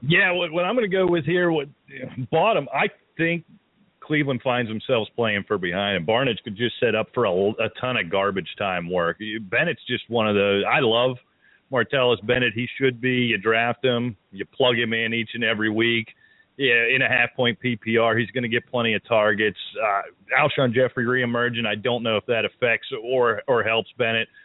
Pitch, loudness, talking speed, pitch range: 120 Hz, -22 LUFS, 205 wpm, 115-130 Hz